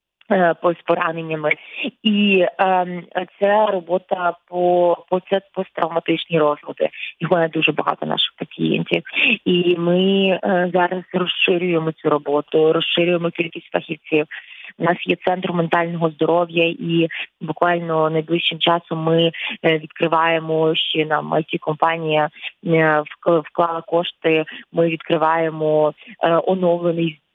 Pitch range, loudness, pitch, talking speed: 160-180 Hz, -19 LUFS, 170 Hz, 100 wpm